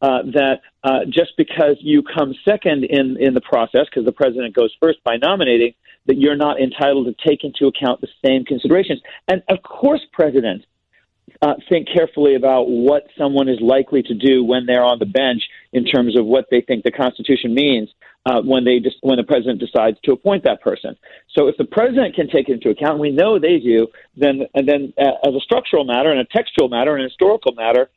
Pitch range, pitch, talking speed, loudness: 125-150 Hz, 135 Hz, 215 wpm, -16 LUFS